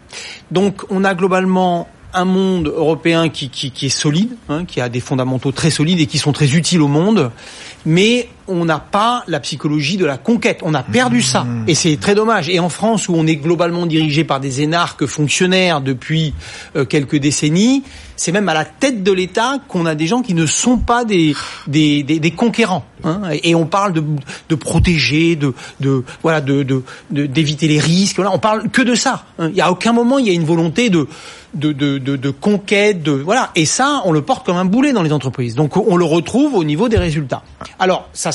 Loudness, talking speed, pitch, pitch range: -15 LUFS, 215 wpm, 165 Hz, 150-195 Hz